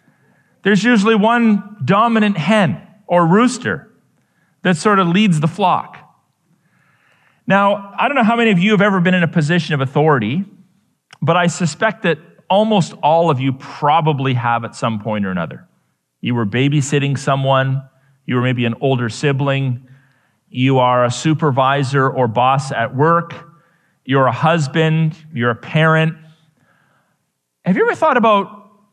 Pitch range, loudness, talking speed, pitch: 135-195 Hz, -15 LUFS, 150 wpm, 160 Hz